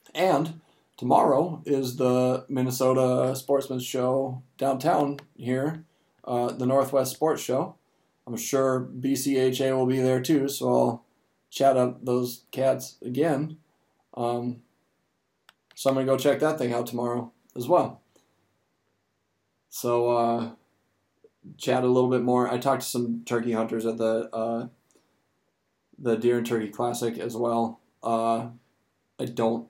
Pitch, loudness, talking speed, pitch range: 125 Hz, -26 LUFS, 135 wpm, 120-135 Hz